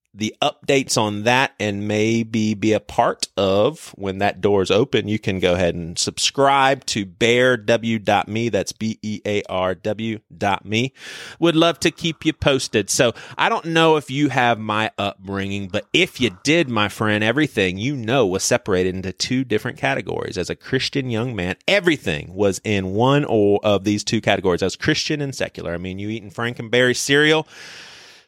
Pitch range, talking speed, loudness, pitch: 100-135 Hz, 175 wpm, -20 LUFS, 110 Hz